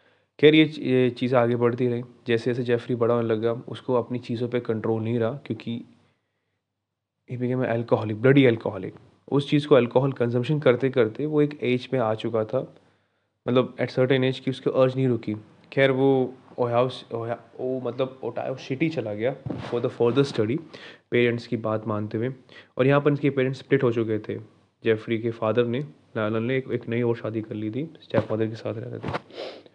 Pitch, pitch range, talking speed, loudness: 120 Hz, 115-130 Hz, 190 wpm, -25 LUFS